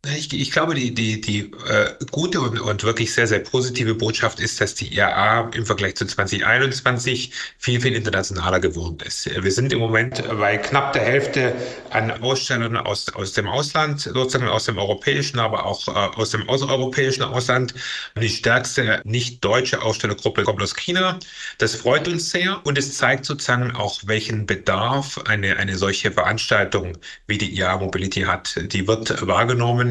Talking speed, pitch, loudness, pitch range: 165 wpm, 115 Hz, -20 LUFS, 105-130 Hz